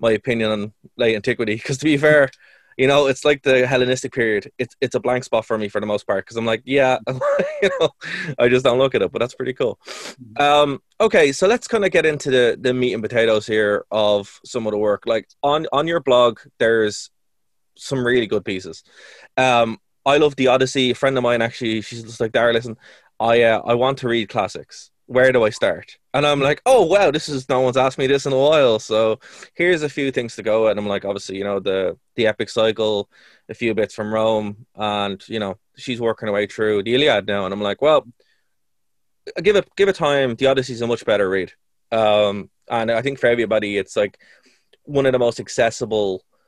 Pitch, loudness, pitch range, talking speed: 120 Hz, -19 LUFS, 110-135 Hz, 230 wpm